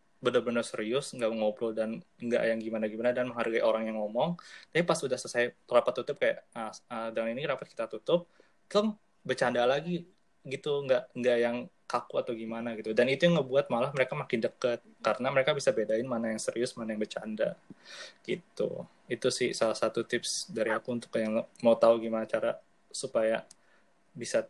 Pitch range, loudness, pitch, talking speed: 110-125 Hz, -31 LUFS, 115 Hz, 175 wpm